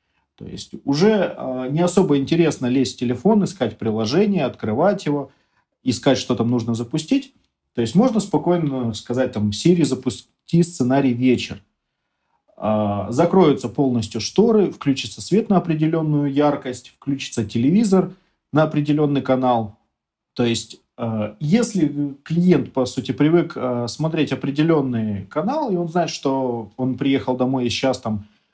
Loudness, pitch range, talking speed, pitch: -20 LUFS, 120-165 Hz, 135 wpm, 135 Hz